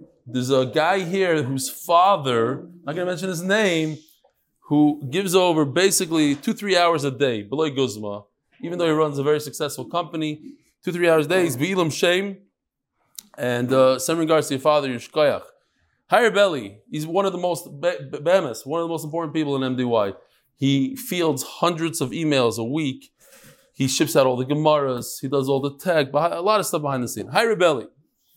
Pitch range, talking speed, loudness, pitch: 135-175 Hz, 190 wpm, -21 LUFS, 155 Hz